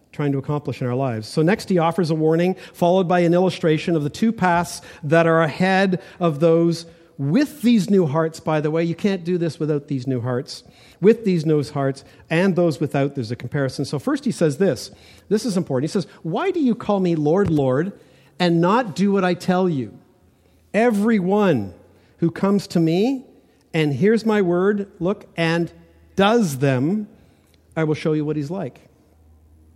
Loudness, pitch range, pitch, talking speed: -20 LUFS, 150-190 Hz, 170 Hz, 190 wpm